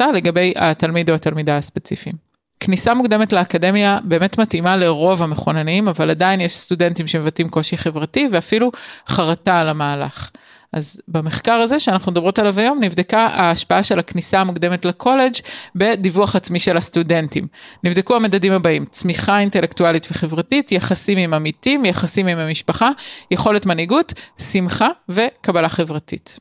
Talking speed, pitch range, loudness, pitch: 130 wpm, 170-205 Hz, -17 LUFS, 180 Hz